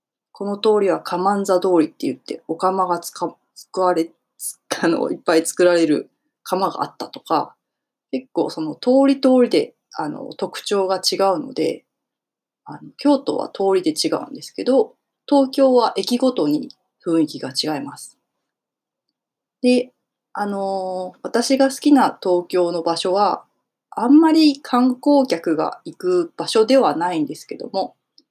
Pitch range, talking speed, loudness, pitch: 180-270 Hz, 260 characters per minute, -19 LUFS, 205 Hz